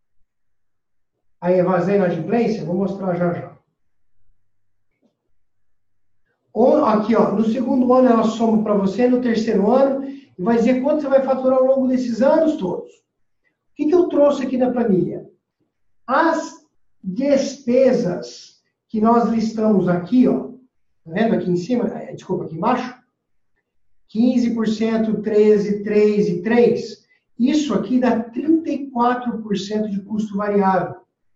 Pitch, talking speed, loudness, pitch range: 220 Hz, 130 wpm, -18 LUFS, 185-255 Hz